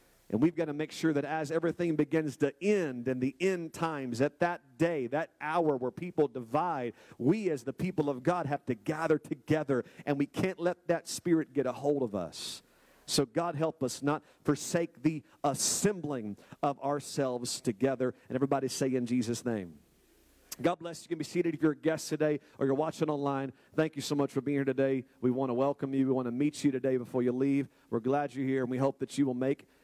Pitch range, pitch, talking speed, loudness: 130-160 Hz, 145 Hz, 225 wpm, -32 LUFS